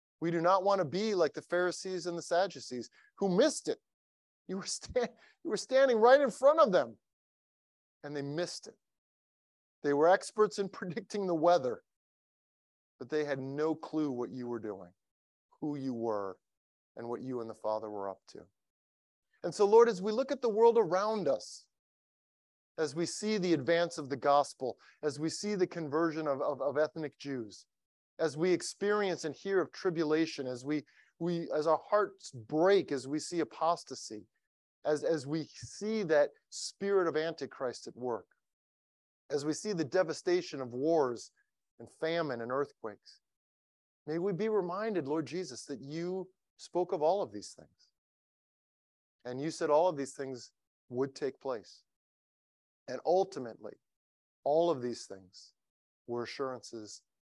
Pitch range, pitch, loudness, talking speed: 130-185 Hz, 160 Hz, -33 LUFS, 165 wpm